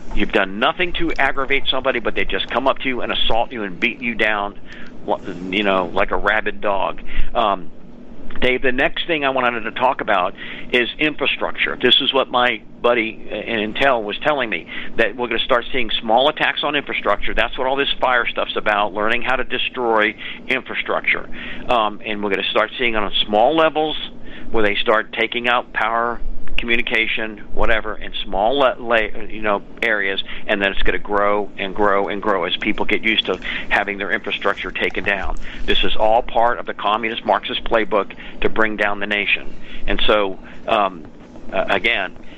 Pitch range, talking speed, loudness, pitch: 105-125 Hz, 190 wpm, -19 LUFS, 115 Hz